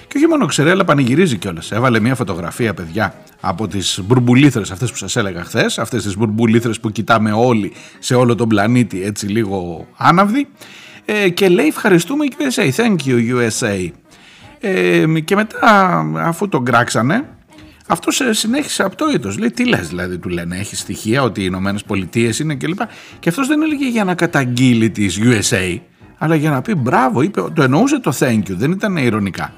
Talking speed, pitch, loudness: 175 wpm, 120 Hz, -15 LUFS